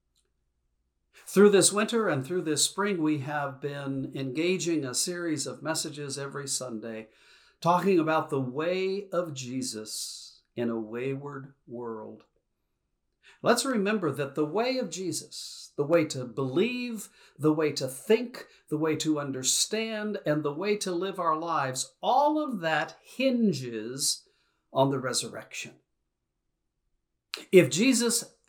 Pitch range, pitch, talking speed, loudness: 135-190 Hz, 155 Hz, 130 wpm, -28 LUFS